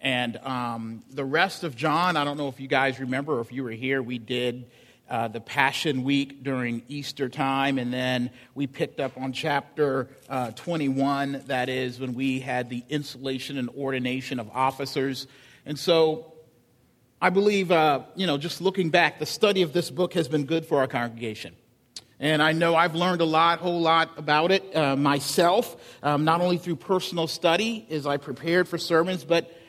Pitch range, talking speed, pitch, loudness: 130-165 Hz, 190 wpm, 140 Hz, -25 LUFS